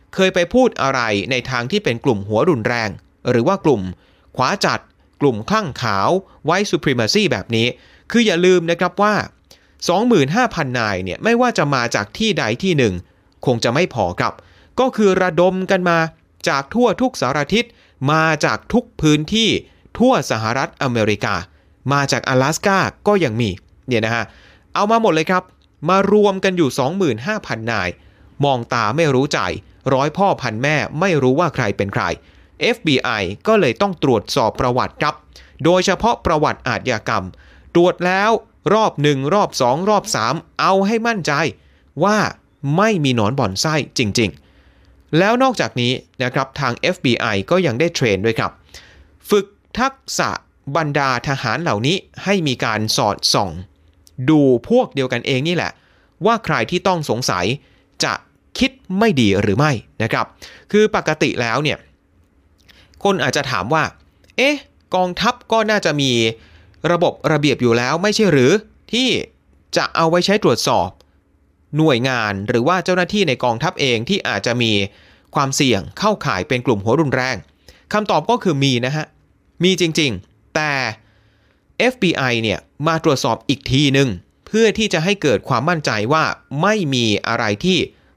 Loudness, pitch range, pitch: -17 LUFS, 110-185 Hz, 140 Hz